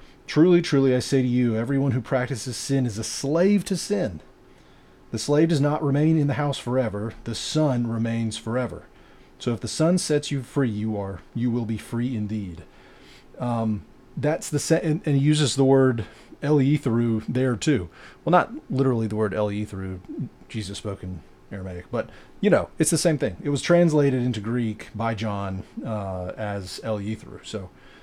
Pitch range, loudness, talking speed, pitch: 110-145 Hz, -24 LUFS, 180 wpm, 120 Hz